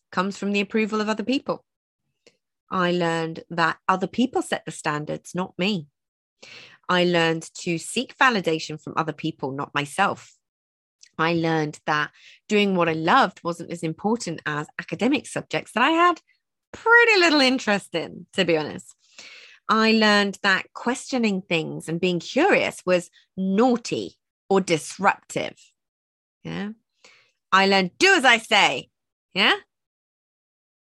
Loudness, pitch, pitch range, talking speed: -22 LUFS, 185 Hz, 160-220 Hz, 135 wpm